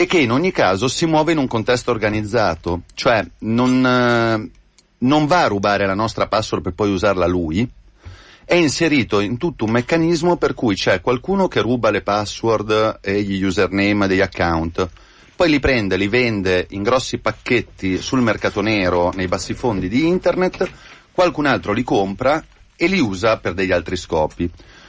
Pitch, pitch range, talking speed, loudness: 110 Hz, 95-130 Hz, 170 wpm, -18 LUFS